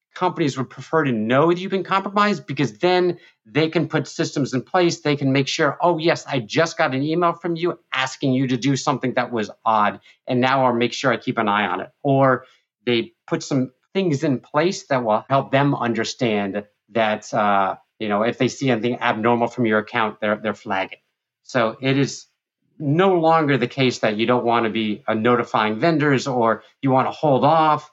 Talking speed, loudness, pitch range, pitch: 210 wpm, -20 LUFS, 115-155 Hz, 130 Hz